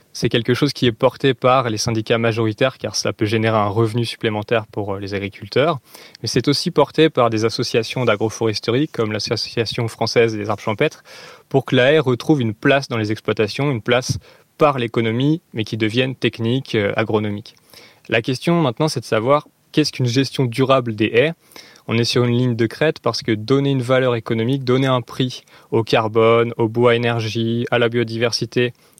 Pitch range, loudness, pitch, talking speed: 115-135 Hz, -19 LUFS, 120 Hz, 185 wpm